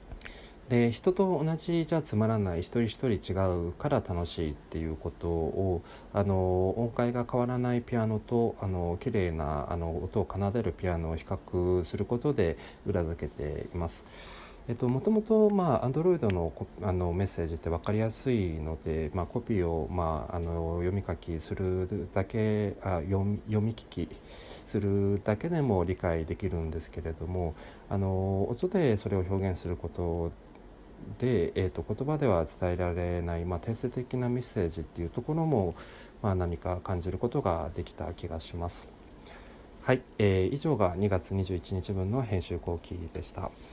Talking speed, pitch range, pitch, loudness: 295 characters per minute, 85-115 Hz, 95 Hz, -31 LUFS